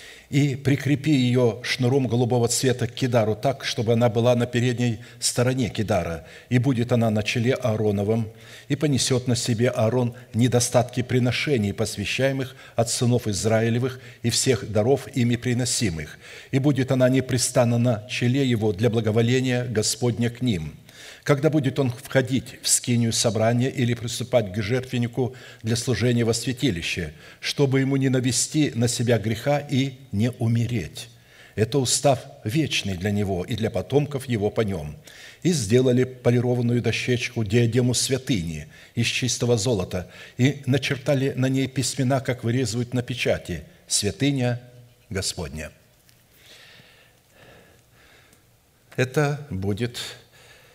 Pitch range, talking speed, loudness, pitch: 115-130 Hz, 130 wpm, -23 LUFS, 125 Hz